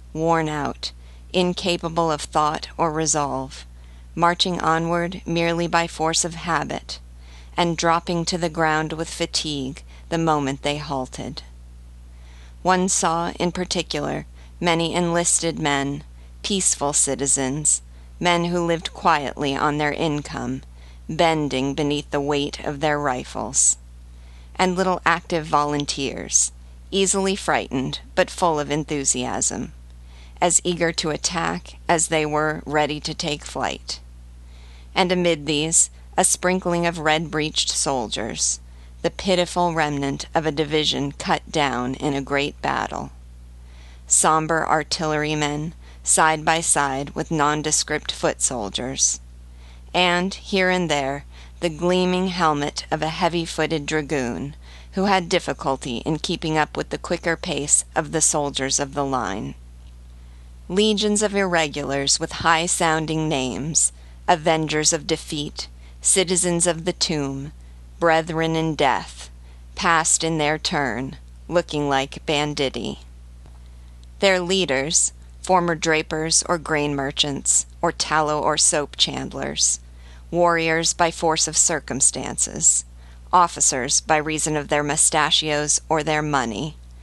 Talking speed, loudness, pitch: 120 wpm, -21 LUFS, 150 Hz